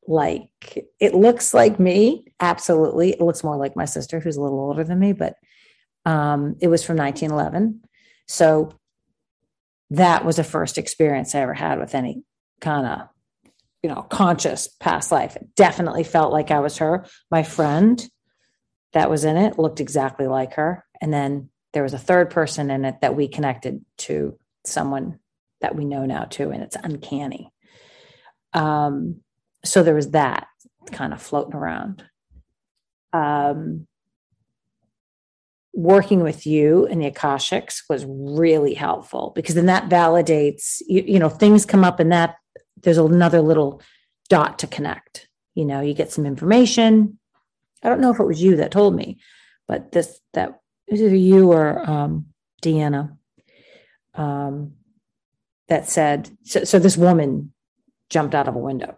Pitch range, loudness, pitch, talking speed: 145-180 Hz, -19 LUFS, 160 Hz, 160 wpm